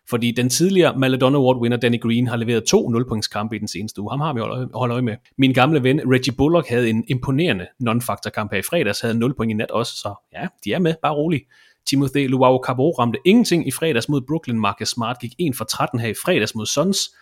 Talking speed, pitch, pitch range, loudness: 240 wpm, 125 Hz, 115-140 Hz, -19 LUFS